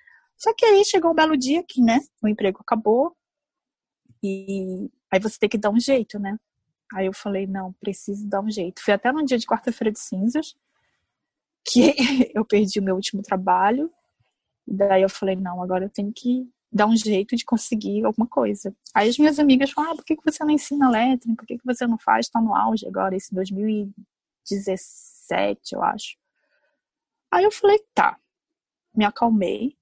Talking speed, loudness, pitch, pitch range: 185 wpm, -22 LUFS, 225 Hz, 200-275 Hz